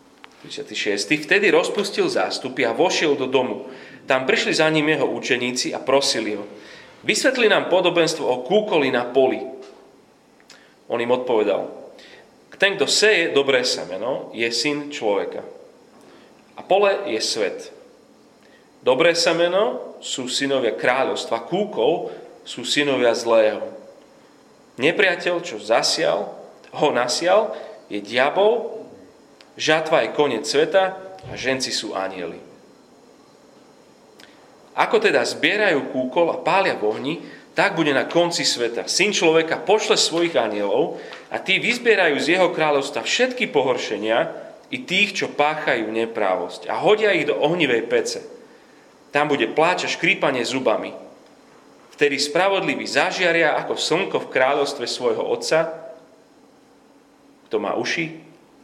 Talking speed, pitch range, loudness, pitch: 120 wpm, 135-215 Hz, -20 LUFS, 165 Hz